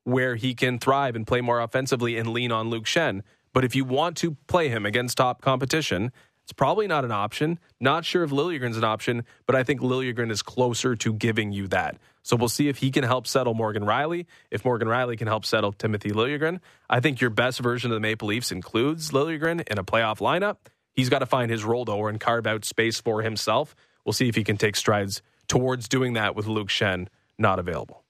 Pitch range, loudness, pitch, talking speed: 110-130 Hz, -25 LUFS, 120 Hz, 225 wpm